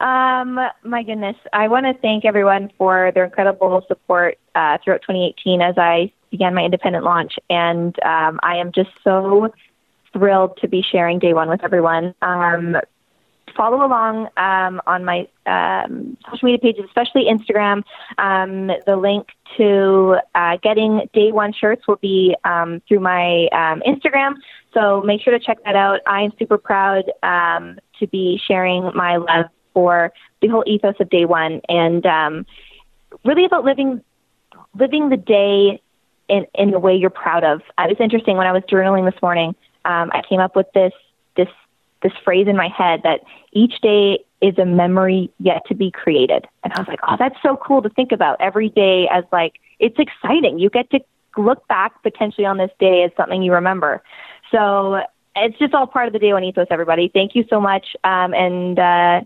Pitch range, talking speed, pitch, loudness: 180-220 Hz, 185 wpm, 195 Hz, -16 LUFS